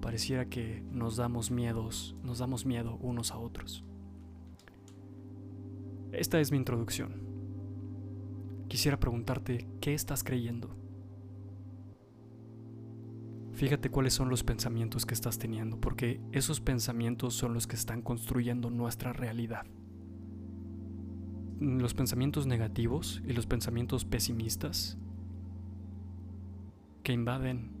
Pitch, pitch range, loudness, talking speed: 115 Hz, 95-120 Hz, -35 LUFS, 100 wpm